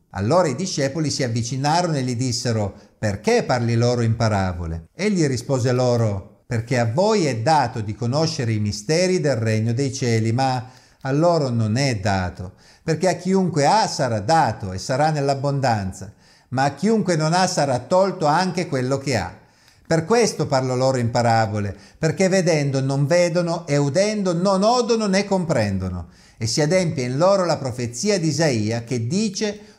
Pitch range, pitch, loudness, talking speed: 115-175 Hz, 135 Hz, -20 LUFS, 165 wpm